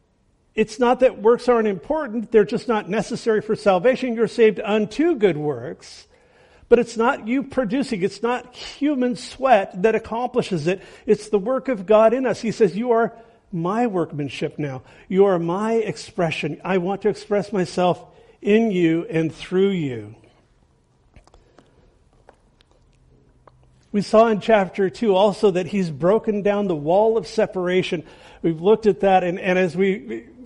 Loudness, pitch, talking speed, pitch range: -20 LUFS, 205 Hz, 155 wpm, 180-230 Hz